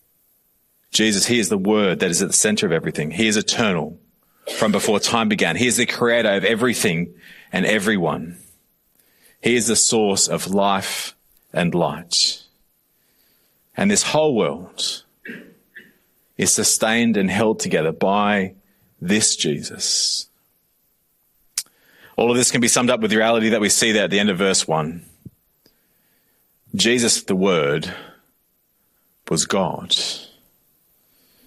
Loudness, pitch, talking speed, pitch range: -18 LUFS, 110 Hz, 135 wpm, 100-120 Hz